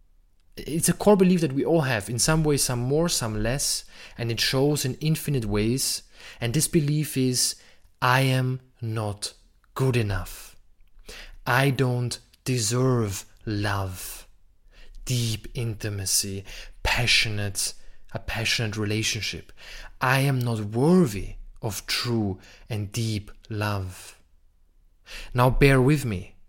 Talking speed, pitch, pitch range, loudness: 120 wpm, 115 Hz, 105-130 Hz, -24 LUFS